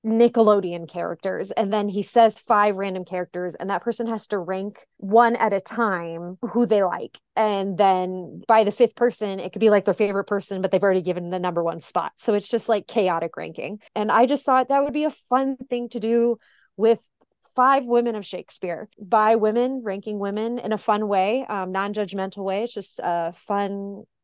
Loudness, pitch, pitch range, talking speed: -22 LUFS, 210 Hz, 190-235 Hz, 205 wpm